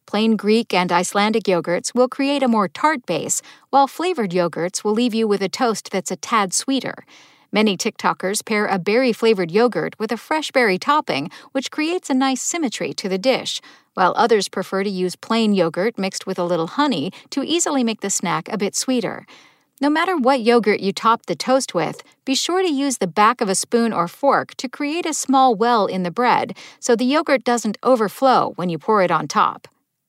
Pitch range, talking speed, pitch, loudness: 195-270 Hz, 205 wpm, 230 Hz, -19 LUFS